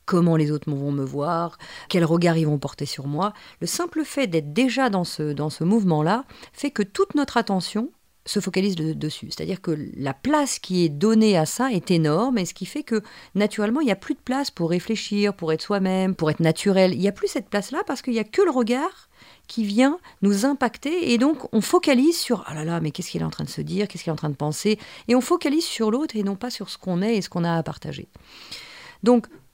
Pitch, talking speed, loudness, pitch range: 200 Hz, 250 wpm, -23 LUFS, 165-250 Hz